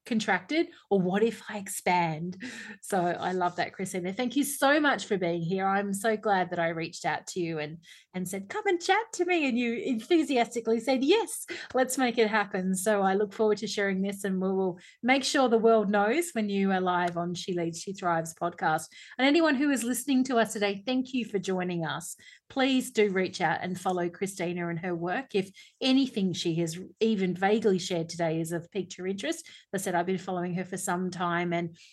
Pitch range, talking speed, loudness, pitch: 180-235 Hz, 215 wpm, -28 LUFS, 195 Hz